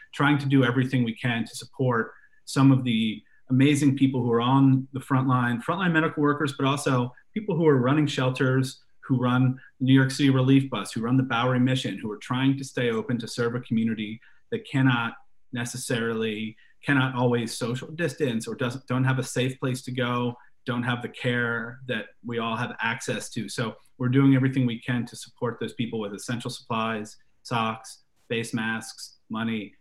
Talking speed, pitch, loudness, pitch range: 190 wpm, 125 Hz, -25 LUFS, 120-135 Hz